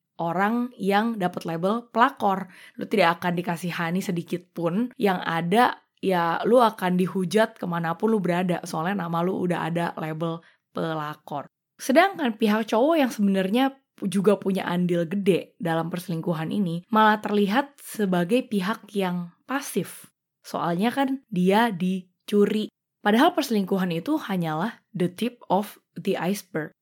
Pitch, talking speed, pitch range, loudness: 195 Hz, 130 wpm, 175-220 Hz, -24 LUFS